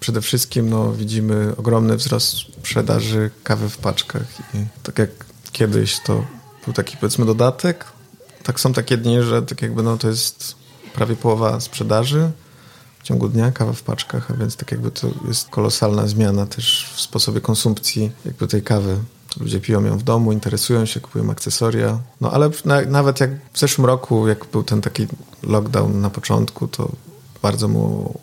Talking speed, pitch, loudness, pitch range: 170 wpm, 115 Hz, -19 LUFS, 110-130 Hz